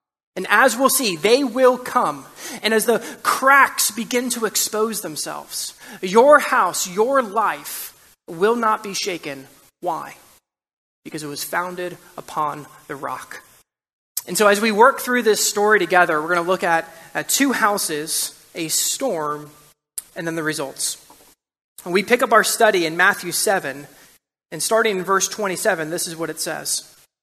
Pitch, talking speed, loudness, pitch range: 195 Hz, 160 wpm, -19 LUFS, 165-225 Hz